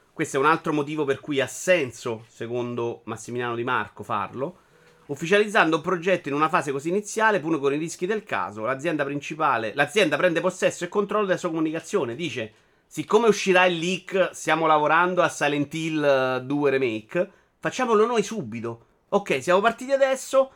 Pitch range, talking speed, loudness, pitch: 140-185 Hz, 165 wpm, -24 LUFS, 160 Hz